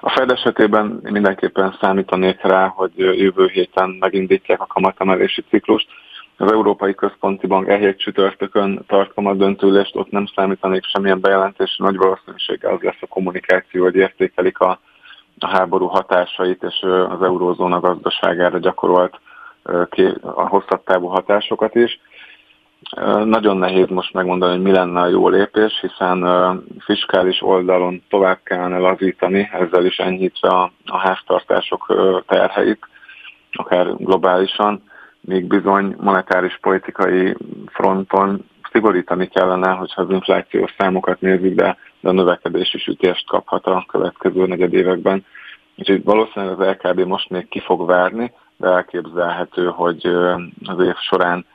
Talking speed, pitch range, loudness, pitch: 125 wpm, 90-100 Hz, -17 LUFS, 95 Hz